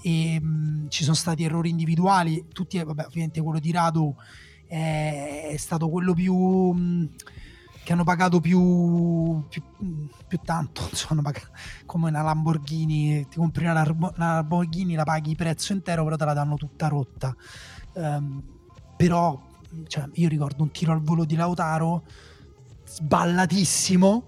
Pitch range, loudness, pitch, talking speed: 150-170 Hz, -24 LUFS, 160 Hz, 145 wpm